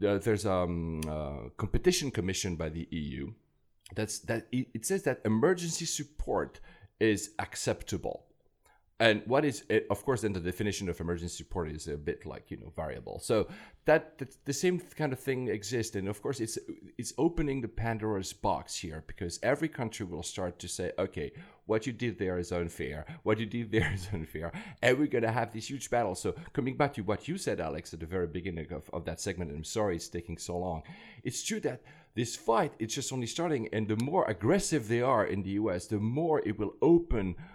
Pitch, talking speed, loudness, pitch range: 110 Hz, 210 wpm, -33 LUFS, 90-130 Hz